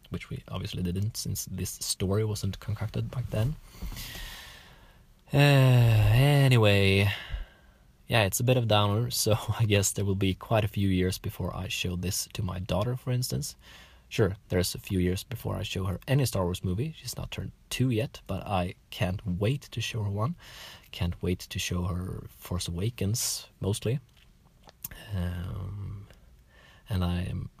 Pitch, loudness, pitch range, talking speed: 105 Hz, -28 LUFS, 90-115 Hz, 165 wpm